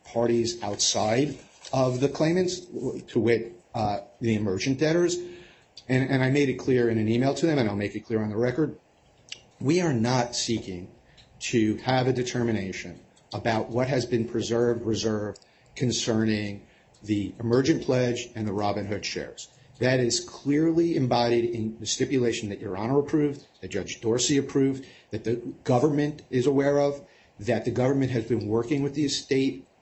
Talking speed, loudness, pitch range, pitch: 165 wpm, -26 LUFS, 115-135 Hz, 120 Hz